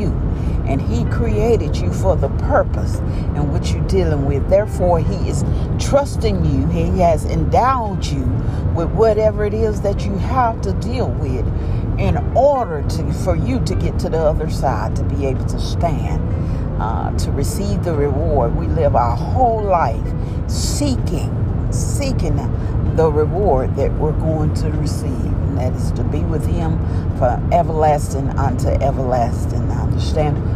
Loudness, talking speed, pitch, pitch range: -18 LUFS, 155 wpm, 95 Hz, 85-110 Hz